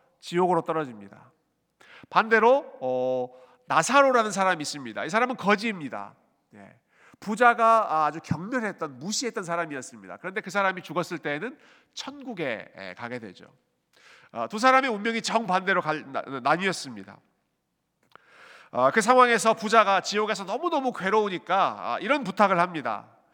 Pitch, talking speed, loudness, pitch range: 205 Hz, 320 characters per minute, -24 LUFS, 170-230 Hz